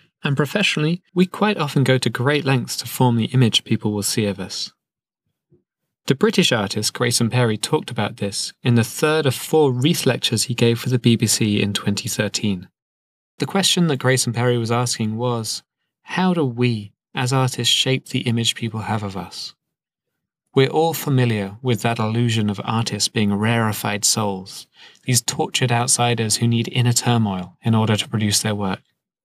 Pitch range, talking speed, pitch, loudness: 110-135 Hz, 170 wpm, 120 Hz, -19 LUFS